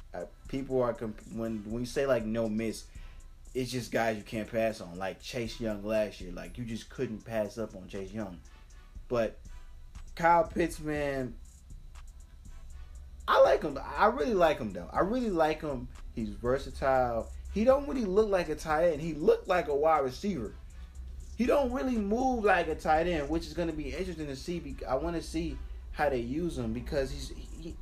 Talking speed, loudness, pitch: 195 wpm, -31 LUFS, 115 Hz